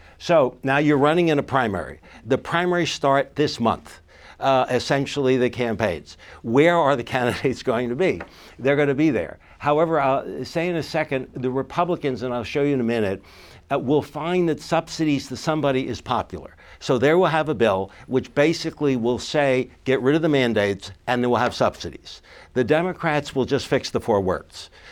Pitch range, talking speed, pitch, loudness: 125-150 Hz, 195 wpm, 135 Hz, -22 LUFS